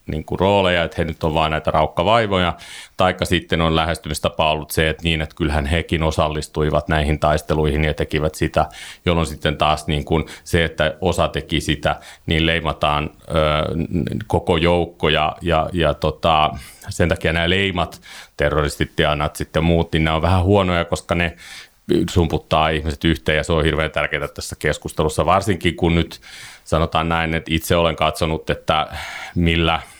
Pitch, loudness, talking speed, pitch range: 80 Hz, -19 LUFS, 160 wpm, 75-85 Hz